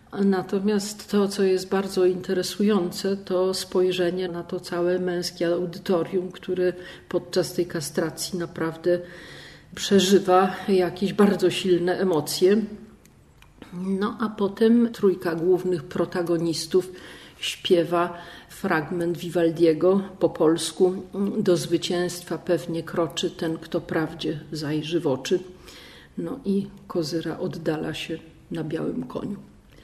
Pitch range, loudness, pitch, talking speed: 170-190 Hz, -24 LUFS, 180 Hz, 105 wpm